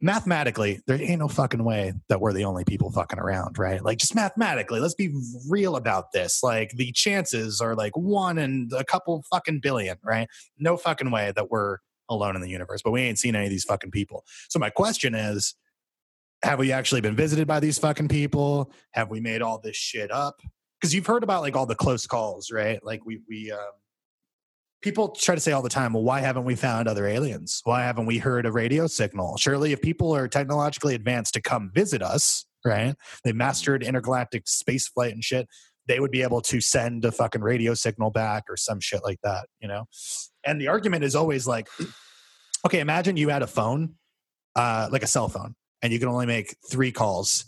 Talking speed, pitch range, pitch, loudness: 210 wpm, 110-145 Hz, 125 Hz, -25 LUFS